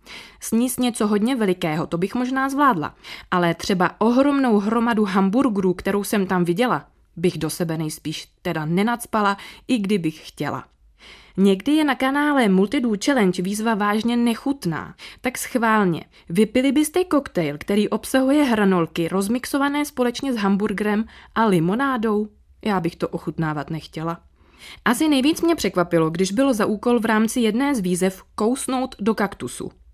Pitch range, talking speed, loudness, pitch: 180-255 Hz, 140 wpm, -21 LUFS, 215 Hz